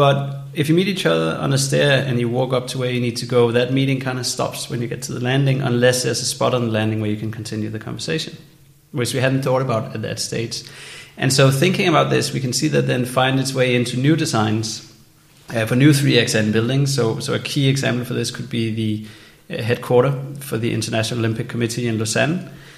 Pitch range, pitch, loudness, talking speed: 115-140 Hz, 125 Hz, -19 LUFS, 235 wpm